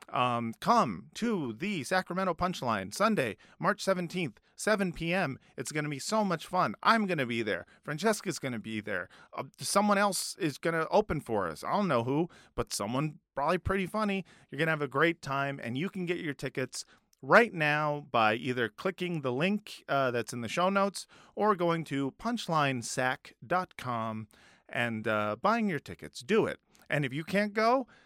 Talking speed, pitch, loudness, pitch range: 190 wpm, 160 Hz, -31 LUFS, 130-195 Hz